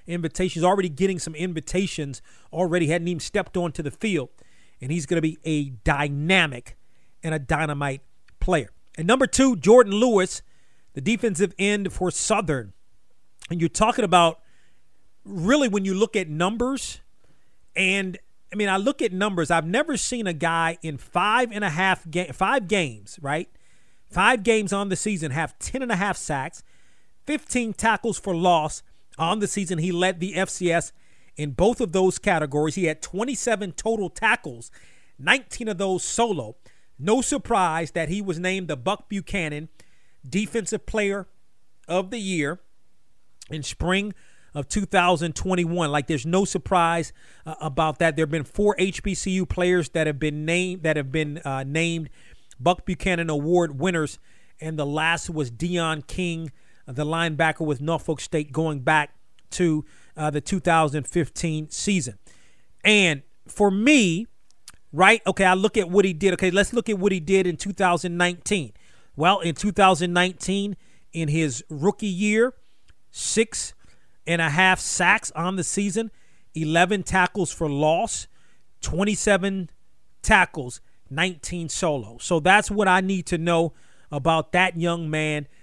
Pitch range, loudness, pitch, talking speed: 155-195 Hz, -23 LUFS, 175 Hz, 150 wpm